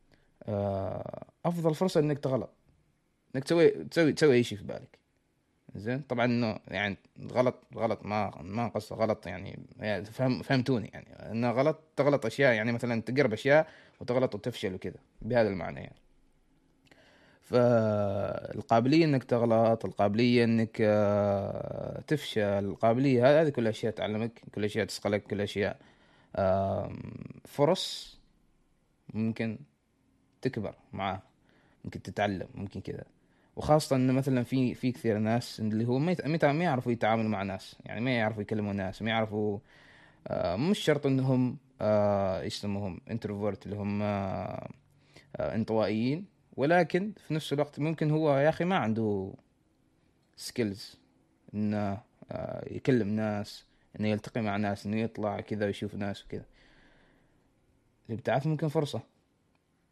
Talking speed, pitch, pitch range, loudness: 130 wpm, 115 Hz, 105-130 Hz, -30 LUFS